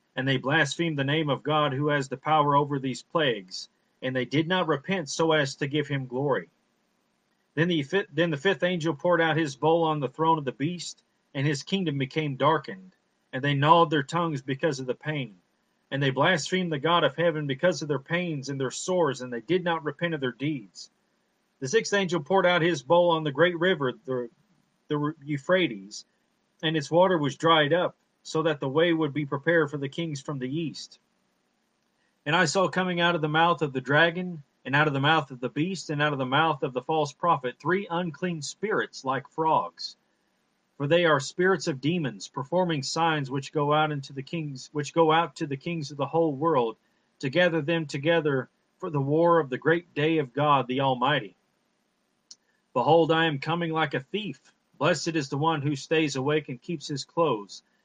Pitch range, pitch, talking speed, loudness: 140-170 Hz, 155 Hz, 205 wpm, -26 LUFS